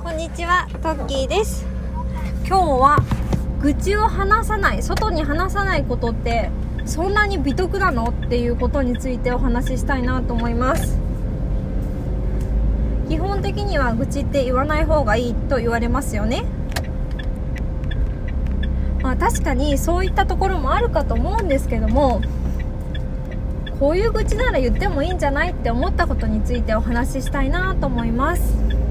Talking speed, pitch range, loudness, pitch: 330 characters per minute, 65-95 Hz, -21 LUFS, 70 Hz